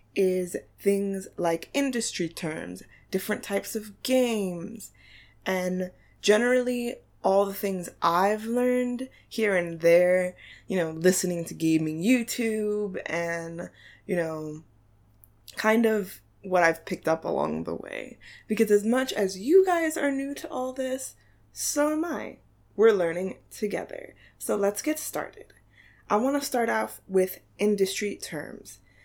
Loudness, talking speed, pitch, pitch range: -27 LUFS, 135 wpm, 195 Hz, 170-235 Hz